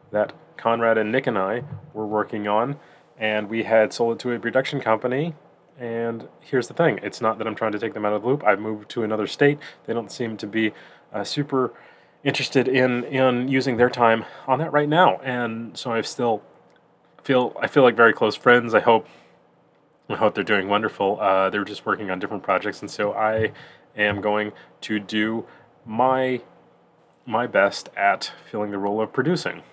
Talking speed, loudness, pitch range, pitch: 200 wpm, -22 LUFS, 110-130 Hz, 115 Hz